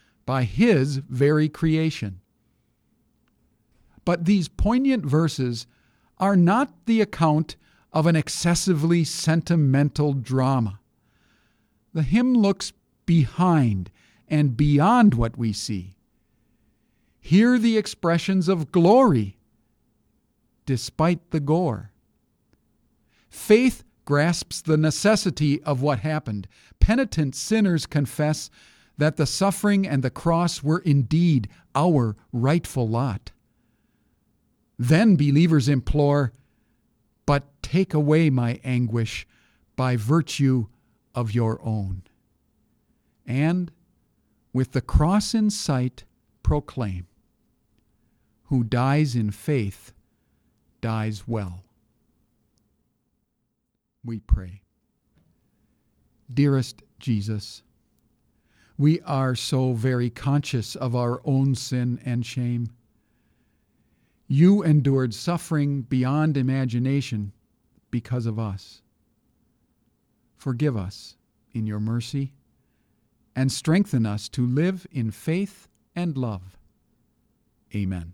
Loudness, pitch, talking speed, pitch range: -23 LUFS, 135 Hz, 90 wpm, 115-160 Hz